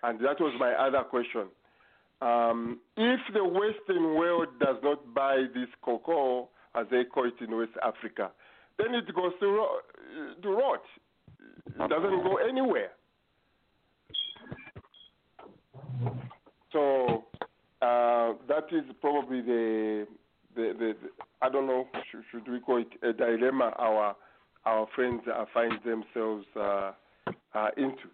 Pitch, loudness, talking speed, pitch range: 125 Hz, -30 LUFS, 130 wpm, 115-160 Hz